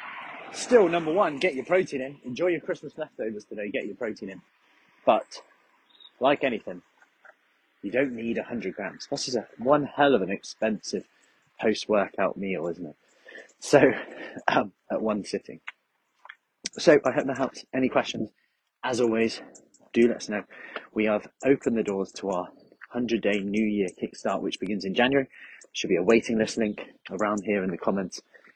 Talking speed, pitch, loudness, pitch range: 170 wpm, 115 Hz, -27 LUFS, 105-135 Hz